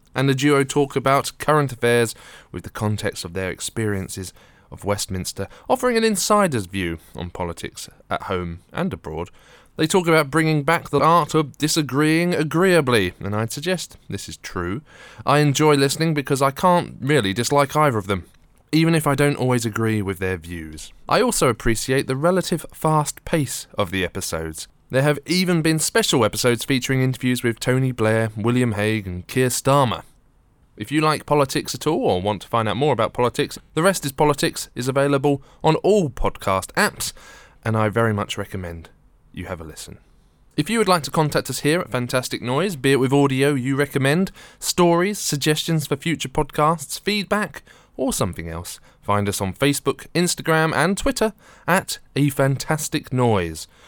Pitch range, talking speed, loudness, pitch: 105-155 Hz, 175 wpm, -21 LUFS, 135 Hz